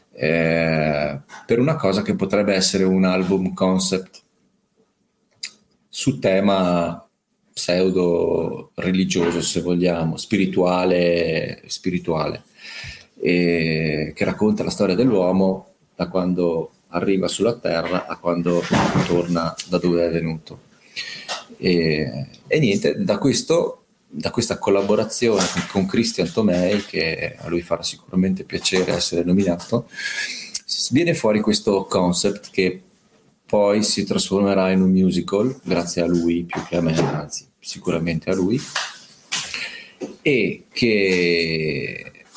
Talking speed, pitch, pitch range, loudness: 110 wpm, 90 Hz, 85-95 Hz, -20 LUFS